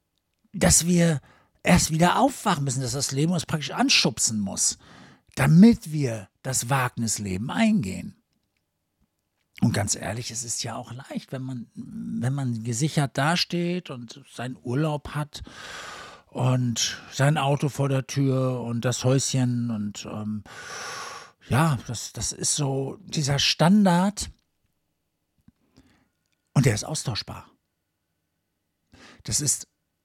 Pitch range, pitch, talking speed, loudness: 115-160 Hz, 135 Hz, 120 wpm, -24 LUFS